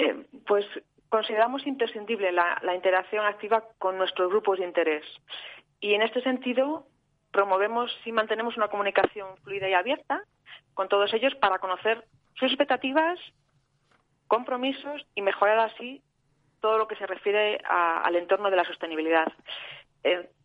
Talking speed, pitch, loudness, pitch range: 140 wpm, 205 Hz, -26 LUFS, 185-230 Hz